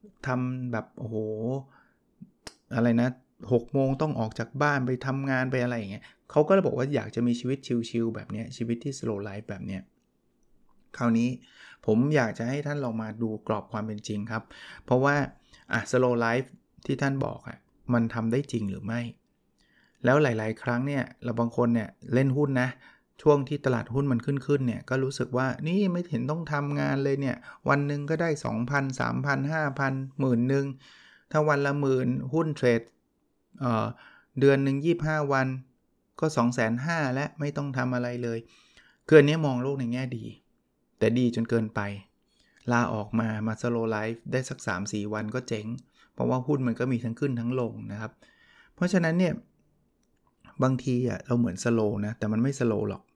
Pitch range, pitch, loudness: 115-140 Hz, 125 Hz, -28 LUFS